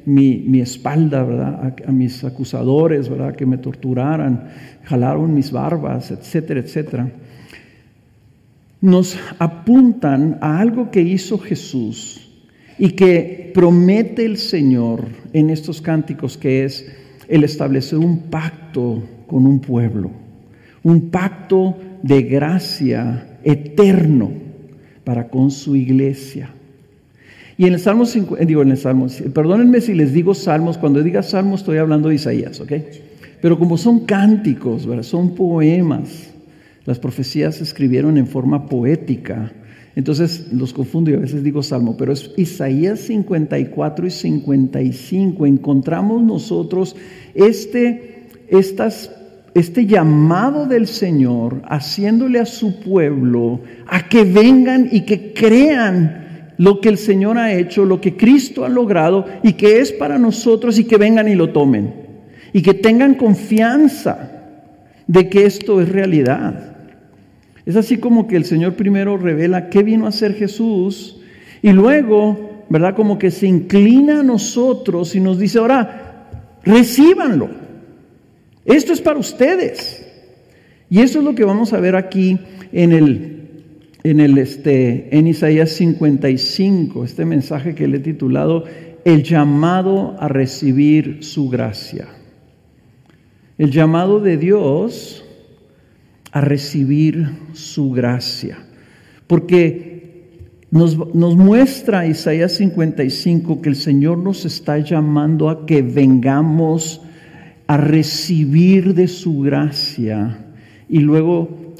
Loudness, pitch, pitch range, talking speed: -15 LUFS, 160 Hz, 140-195 Hz, 130 wpm